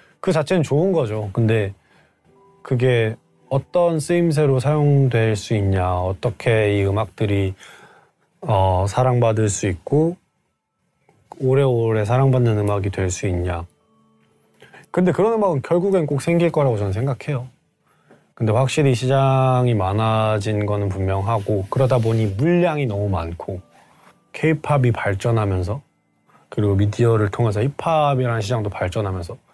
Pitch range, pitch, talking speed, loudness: 100-140 Hz, 115 Hz, 280 characters per minute, -20 LUFS